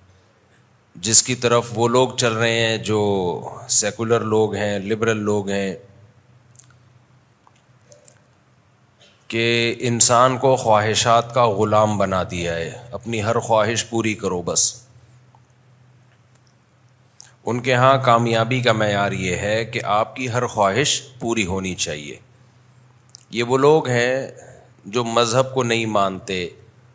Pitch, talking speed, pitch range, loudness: 115 Hz, 120 wpm, 110-125 Hz, -19 LUFS